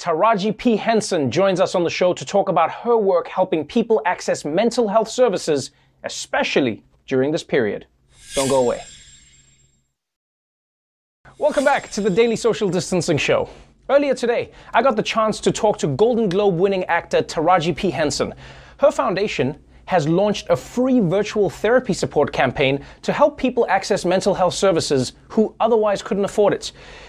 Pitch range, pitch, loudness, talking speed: 175-225 Hz, 200 Hz, -19 LUFS, 160 wpm